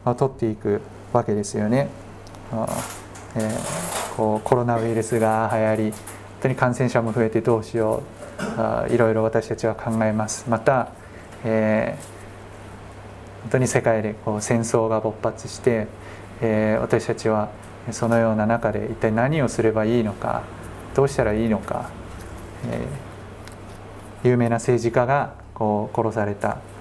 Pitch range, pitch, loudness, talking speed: 105-115 Hz, 110 Hz, -23 LUFS, 270 characters per minute